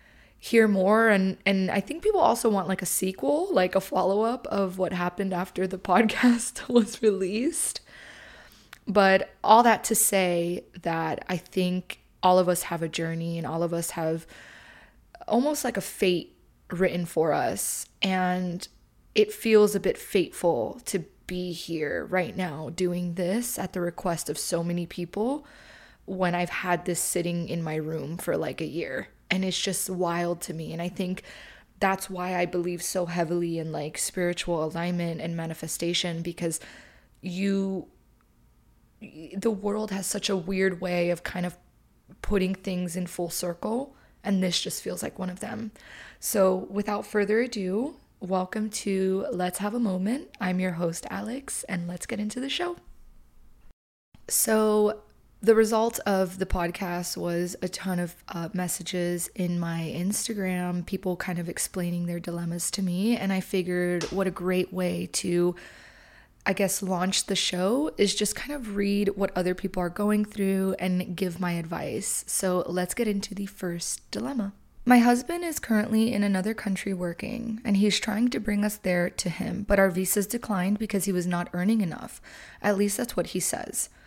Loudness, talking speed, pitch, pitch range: -27 LUFS, 170 wpm, 185 Hz, 175-210 Hz